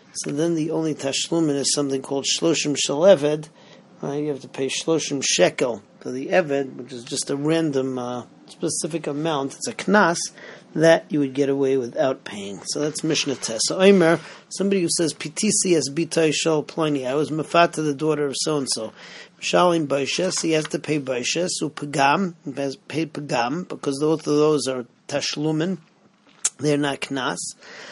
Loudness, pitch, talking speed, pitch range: -22 LUFS, 150 Hz, 165 wpm, 140-165 Hz